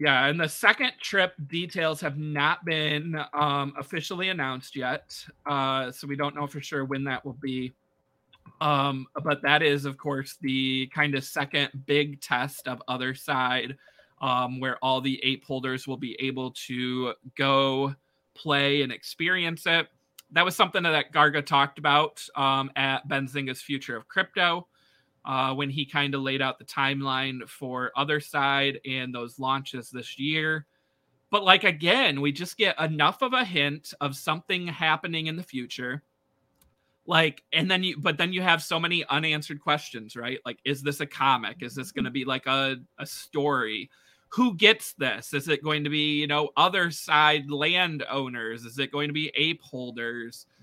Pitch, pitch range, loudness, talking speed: 140 Hz, 130-155 Hz, -26 LUFS, 175 wpm